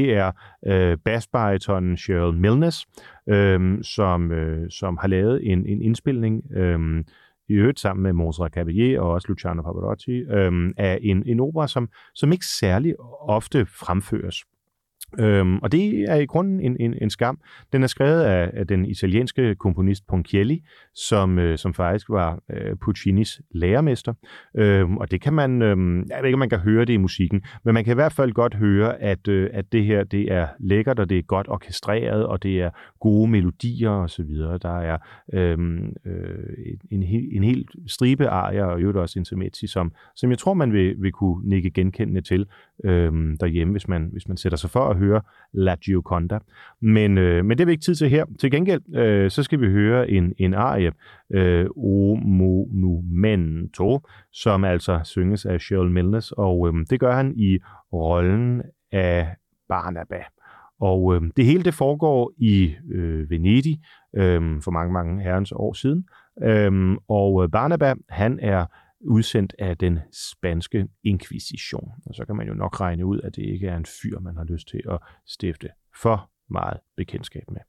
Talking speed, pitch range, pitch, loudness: 180 wpm, 90-115 Hz, 100 Hz, -22 LUFS